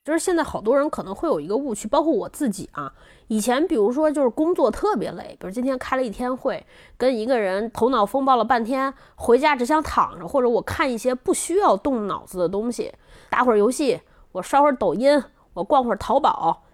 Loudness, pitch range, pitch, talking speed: -21 LUFS, 235-300 Hz, 260 Hz, 325 characters per minute